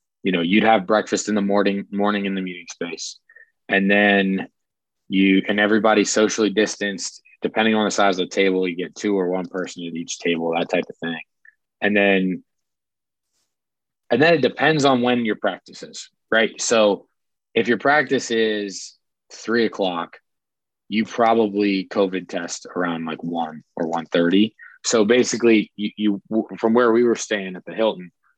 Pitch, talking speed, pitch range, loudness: 100 Hz, 170 wpm, 95-110 Hz, -20 LUFS